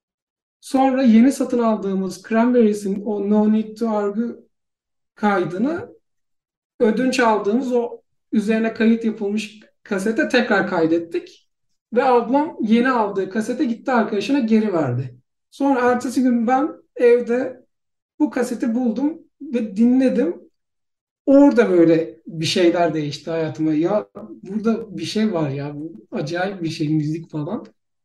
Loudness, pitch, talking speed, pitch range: -19 LUFS, 225 Hz, 120 wpm, 190-250 Hz